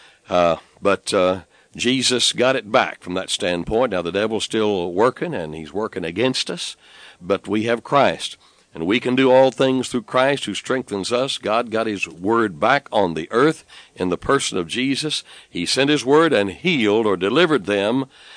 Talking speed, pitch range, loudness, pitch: 185 wpm, 95-130 Hz, -20 LUFS, 115 Hz